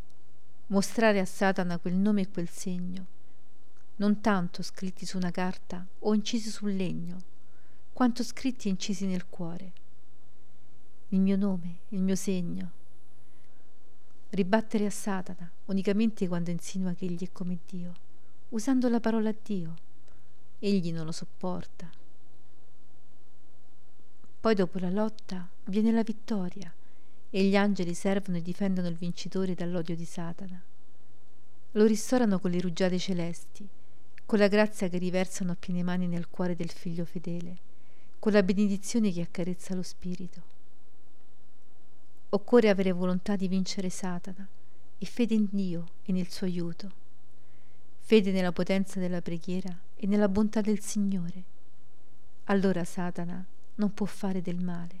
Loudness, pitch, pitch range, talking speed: -30 LUFS, 185 Hz, 180-205 Hz, 135 wpm